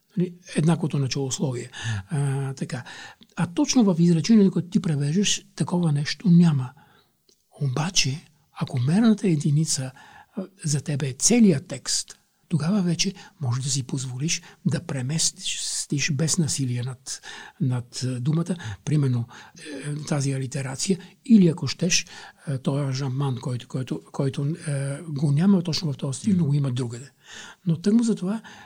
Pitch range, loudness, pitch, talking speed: 135-175 Hz, -24 LUFS, 155 Hz, 135 wpm